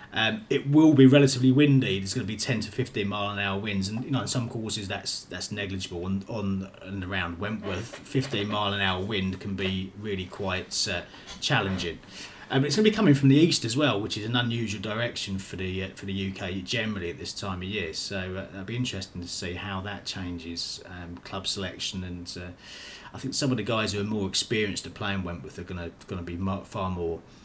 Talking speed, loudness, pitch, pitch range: 235 wpm, -27 LUFS, 100 Hz, 95-115 Hz